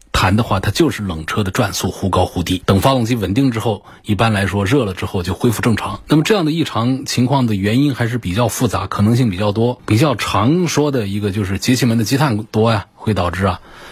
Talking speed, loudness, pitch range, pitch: 350 characters per minute, -16 LUFS, 100-125 Hz, 110 Hz